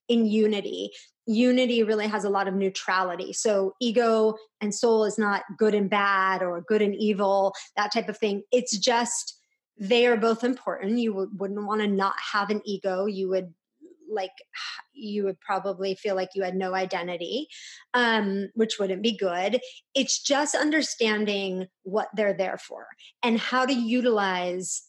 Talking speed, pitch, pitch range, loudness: 165 wpm, 210 Hz, 195-235 Hz, -25 LUFS